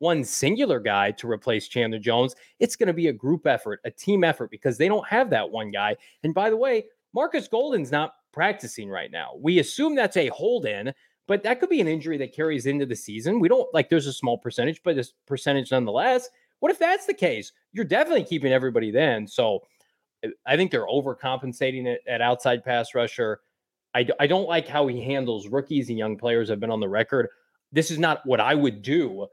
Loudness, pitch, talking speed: -24 LUFS, 145 Hz, 215 wpm